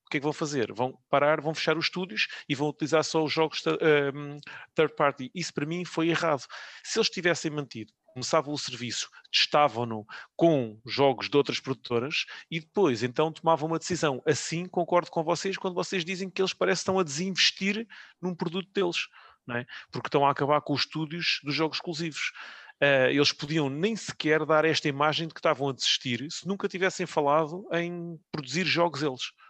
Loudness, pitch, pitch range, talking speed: -27 LUFS, 155 Hz, 145-175 Hz, 190 wpm